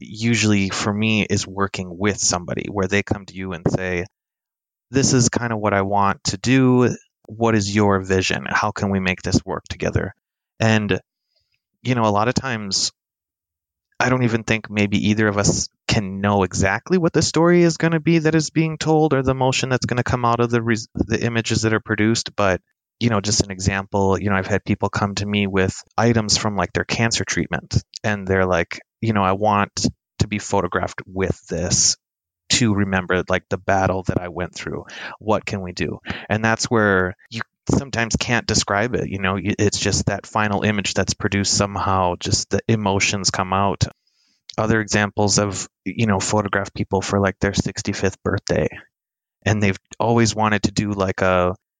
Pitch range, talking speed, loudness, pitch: 95-115 Hz, 195 wpm, -20 LUFS, 100 Hz